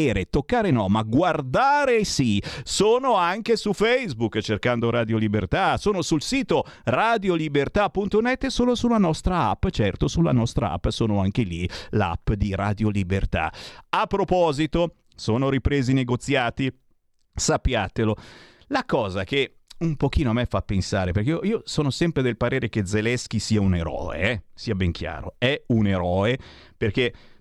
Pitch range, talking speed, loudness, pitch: 105-170 Hz, 145 wpm, -23 LUFS, 125 Hz